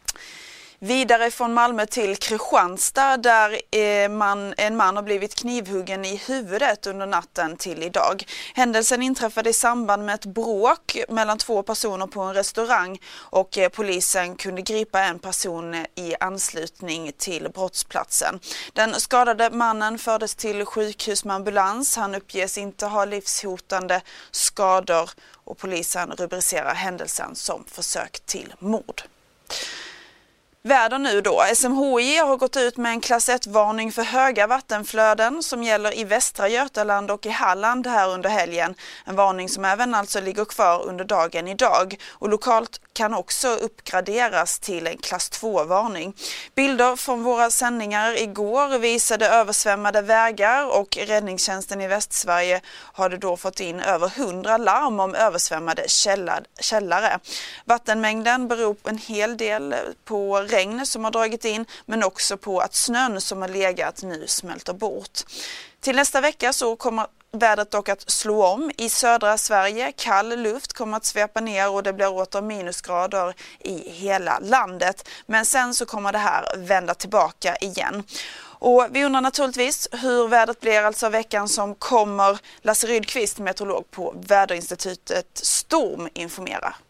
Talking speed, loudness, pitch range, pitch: 140 wpm, -22 LUFS, 195-235 Hz, 210 Hz